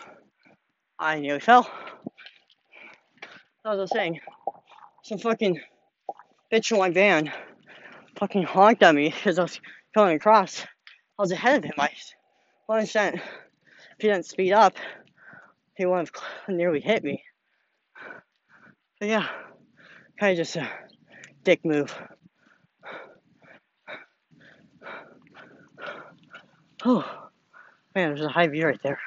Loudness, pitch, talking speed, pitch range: -23 LUFS, 200 Hz, 115 wpm, 170-220 Hz